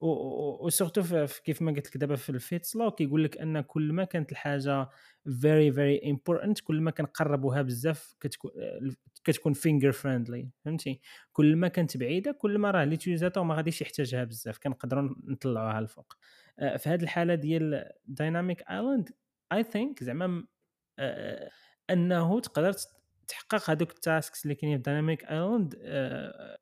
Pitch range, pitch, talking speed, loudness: 140-175 Hz, 155 Hz, 145 wpm, -30 LUFS